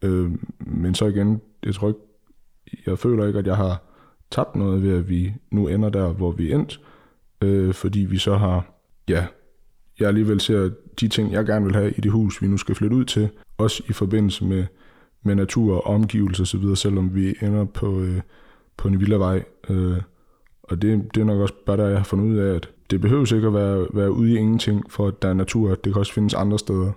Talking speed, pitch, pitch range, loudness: 225 wpm, 100 Hz, 95-105 Hz, -22 LUFS